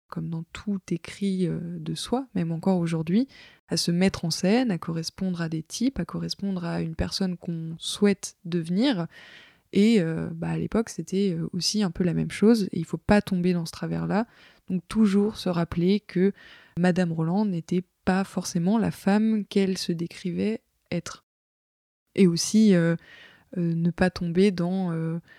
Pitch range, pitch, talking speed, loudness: 170-200 Hz, 180 Hz, 175 wpm, -26 LUFS